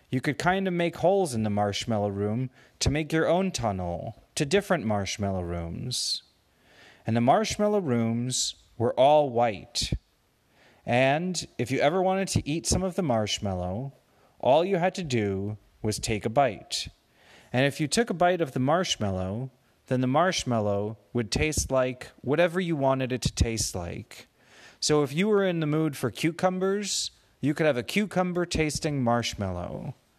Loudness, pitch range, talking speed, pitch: -27 LUFS, 110-165 Hz, 165 wpm, 130 Hz